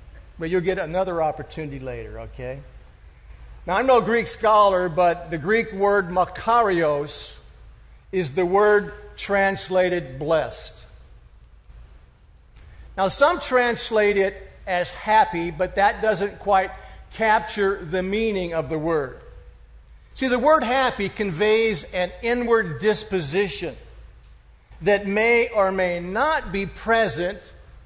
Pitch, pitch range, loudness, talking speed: 190 Hz, 155-215 Hz, -21 LUFS, 115 wpm